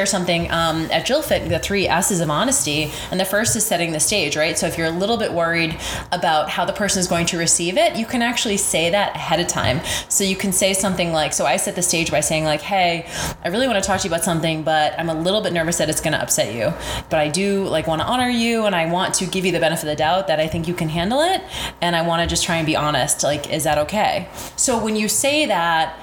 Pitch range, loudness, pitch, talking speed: 160-200 Hz, -19 LUFS, 170 Hz, 280 wpm